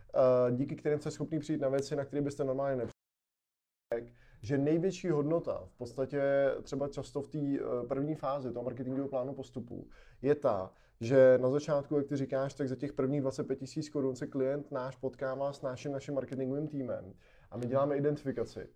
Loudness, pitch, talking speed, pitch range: -34 LUFS, 135 Hz, 175 wpm, 130-145 Hz